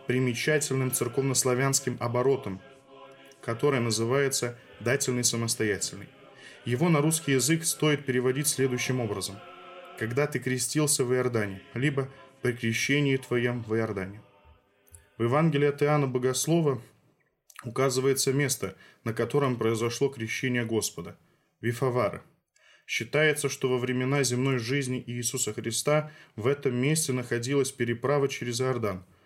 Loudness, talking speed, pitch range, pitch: -27 LUFS, 110 wpm, 115-140 Hz, 130 Hz